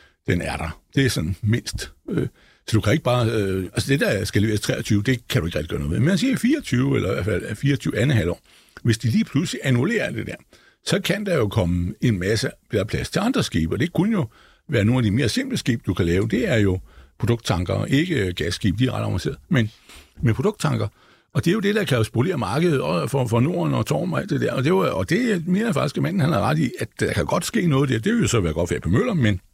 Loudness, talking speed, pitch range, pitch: -22 LUFS, 270 wpm, 105-140 Hz, 120 Hz